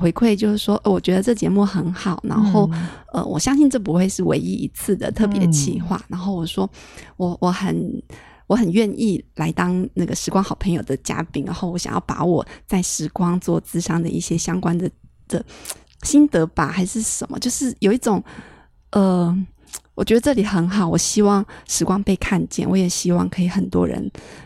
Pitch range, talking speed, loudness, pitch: 175-205 Hz, 275 characters per minute, -20 LUFS, 185 Hz